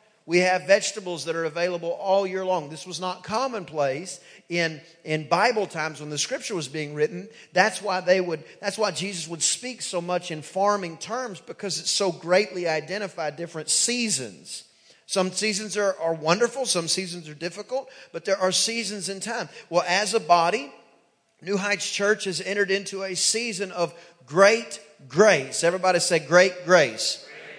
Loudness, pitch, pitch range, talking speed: -24 LUFS, 185 Hz, 170-205 Hz, 170 wpm